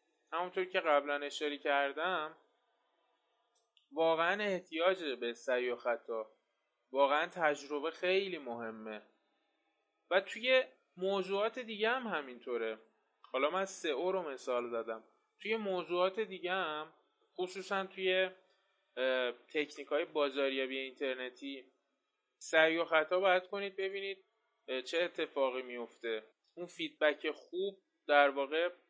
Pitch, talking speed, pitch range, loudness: 165 Hz, 110 wpm, 140-190 Hz, -35 LUFS